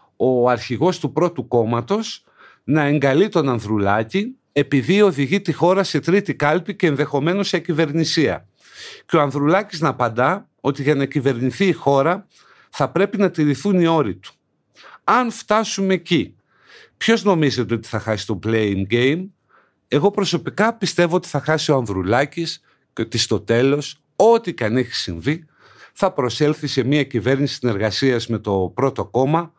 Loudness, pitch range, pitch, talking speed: -19 LUFS, 125-180 Hz, 145 Hz, 155 wpm